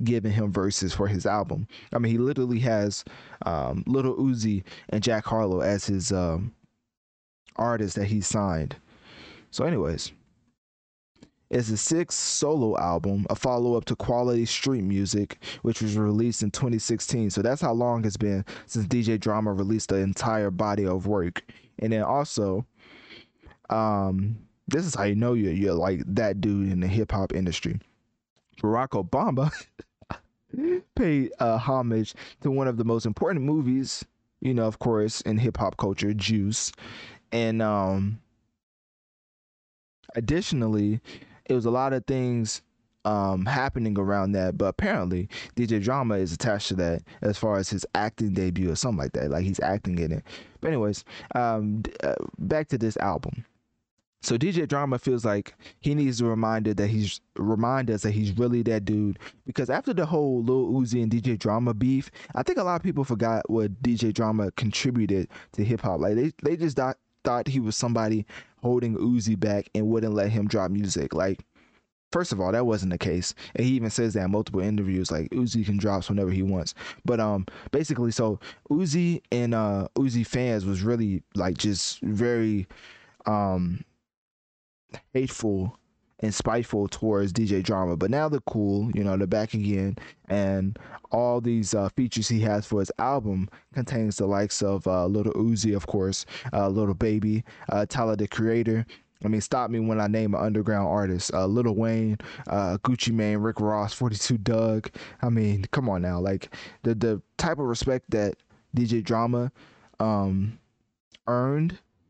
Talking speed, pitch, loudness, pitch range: 170 wpm, 110 Hz, -26 LUFS, 100-120 Hz